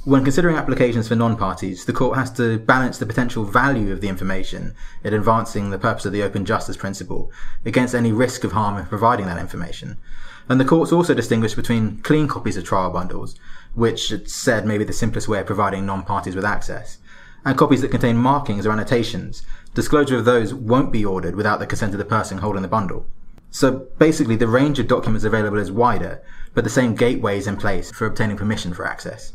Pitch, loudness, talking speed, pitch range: 110 Hz, -20 LUFS, 205 wpm, 100-125 Hz